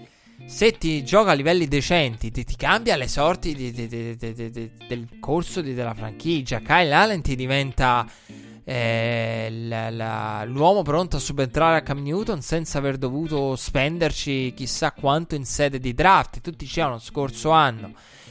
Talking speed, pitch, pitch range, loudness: 165 wpm, 140 Hz, 120-160 Hz, -22 LUFS